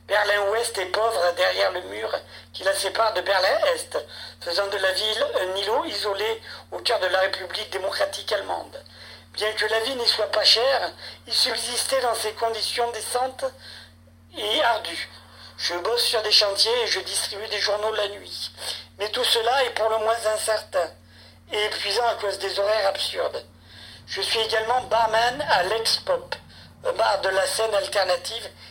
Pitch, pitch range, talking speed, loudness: 220 Hz, 205-235 Hz, 170 wpm, -23 LUFS